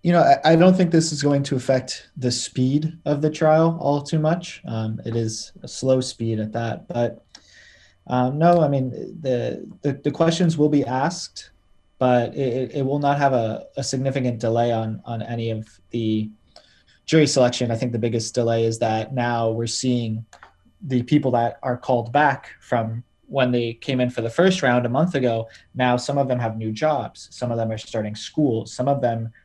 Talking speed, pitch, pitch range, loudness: 200 wpm, 125 Hz, 115-145 Hz, -22 LUFS